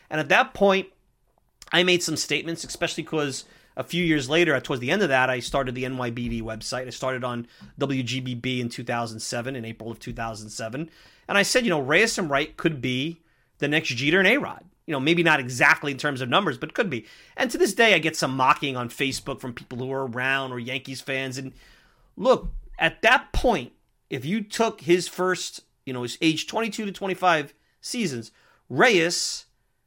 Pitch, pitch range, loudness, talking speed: 140 Hz, 125-170 Hz, -24 LUFS, 195 wpm